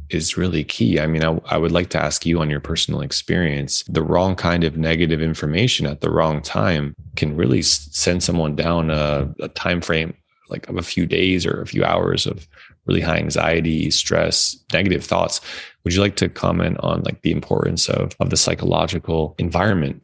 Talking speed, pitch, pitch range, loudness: 195 wpm, 80 Hz, 75-85 Hz, -19 LUFS